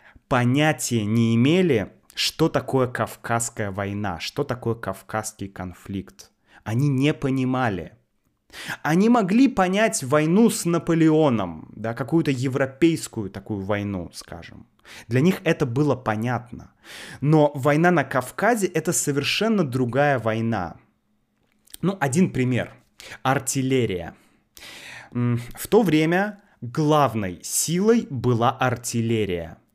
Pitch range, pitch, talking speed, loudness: 110-155 Hz, 130 Hz, 100 wpm, -22 LUFS